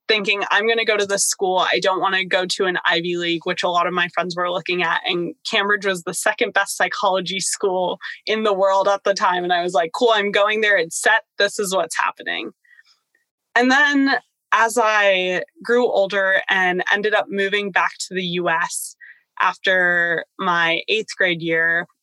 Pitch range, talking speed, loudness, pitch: 180-210 Hz, 200 wpm, -19 LUFS, 195 Hz